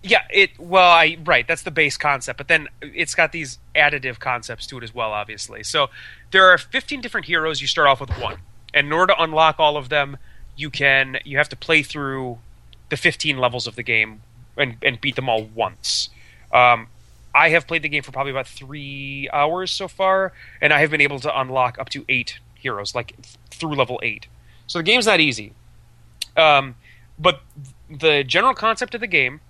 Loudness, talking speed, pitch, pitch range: -18 LUFS, 210 wpm, 140 Hz, 120-160 Hz